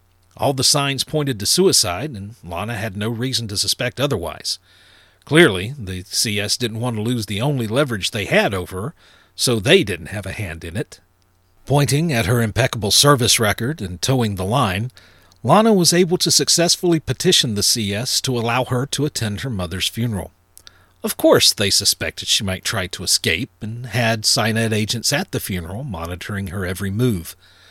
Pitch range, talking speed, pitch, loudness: 95-130 Hz, 180 wpm, 115 Hz, -18 LUFS